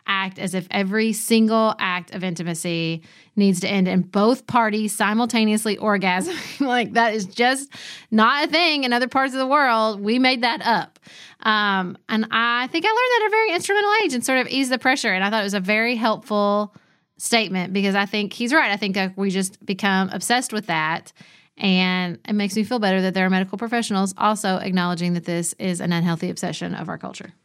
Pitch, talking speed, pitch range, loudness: 210 Hz, 210 wpm, 185-240 Hz, -20 LUFS